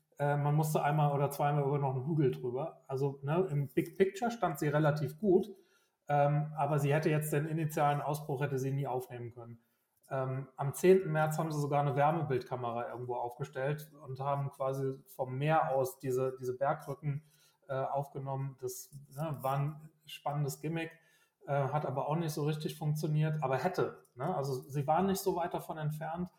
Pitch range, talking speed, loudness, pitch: 135-155 Hz, 180 wpm, -34 LUFS, 145 Hz